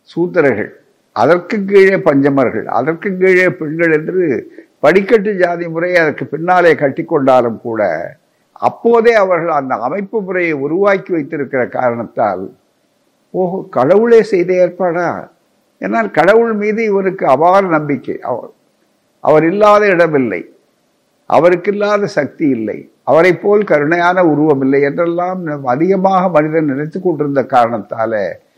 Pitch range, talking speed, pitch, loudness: 155-200 Hz, 110 wpm, 175 Hz, -13 LUFS